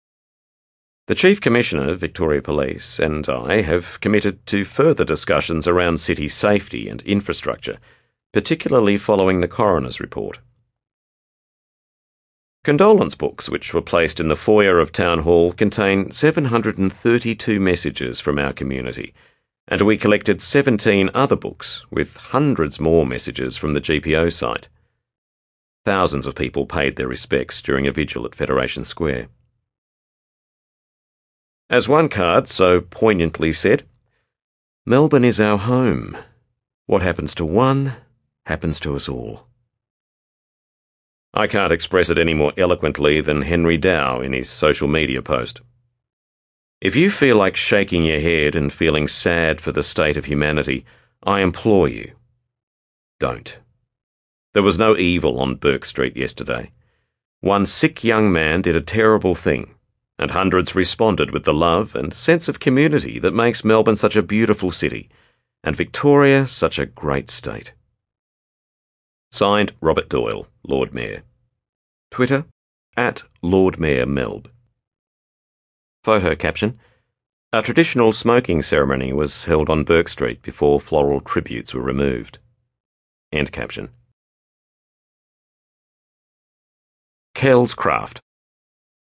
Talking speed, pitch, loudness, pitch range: 125 wpm, 90 Hz, -18 LUFS, 70-115 Hz